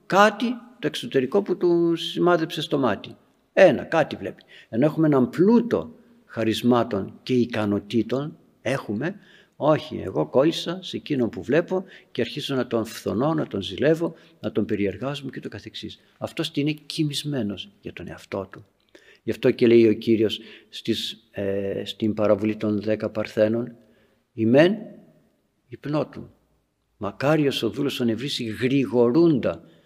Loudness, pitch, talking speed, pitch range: -23 LUFS, 125 Hz, 135 wpm, 110-160 Hz